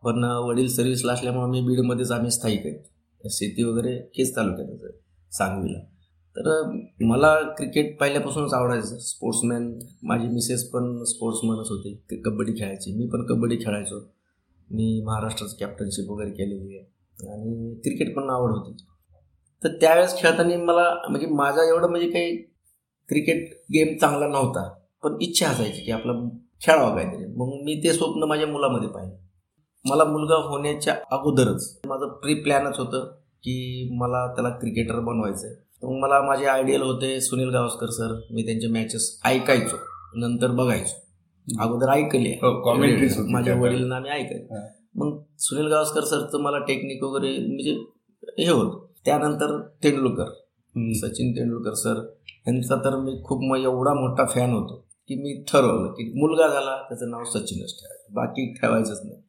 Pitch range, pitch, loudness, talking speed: 115-140 Hz, 125 Hz, -24 LUFS, 145 wpm